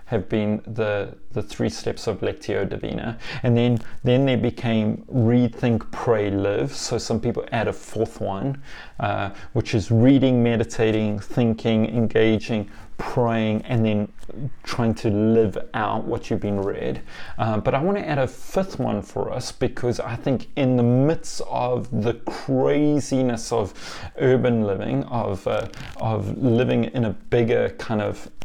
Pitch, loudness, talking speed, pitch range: 115 Hz, -23 LUFS, 155 wpm, 110-125 Hz